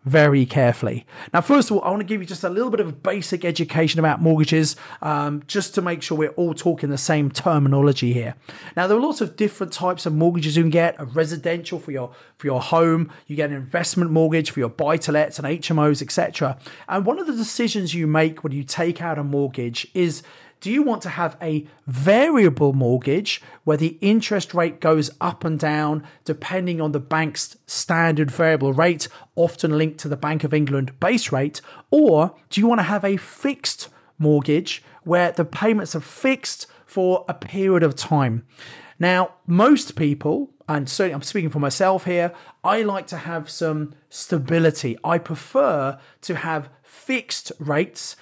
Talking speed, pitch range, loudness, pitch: 190 wpm, 150-185 Hz, -21 LUFS, 165 Hz